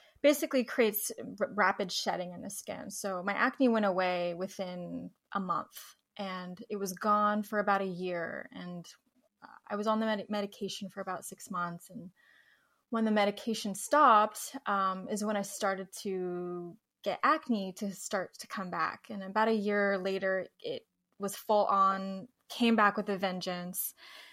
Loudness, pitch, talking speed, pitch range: -32 LUFS, 205 Hz, 165 wpm, 190-220 Hz